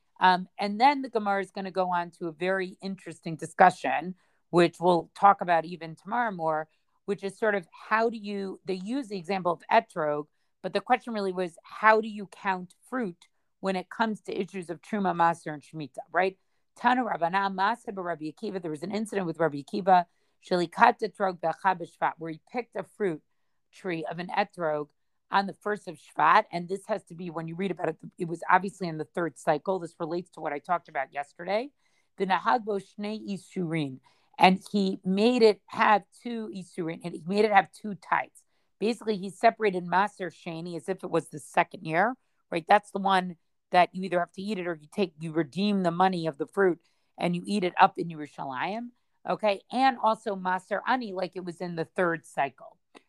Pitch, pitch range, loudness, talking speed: 185 Hz, 170-205 Hz, -28 LUFS, 200 wpm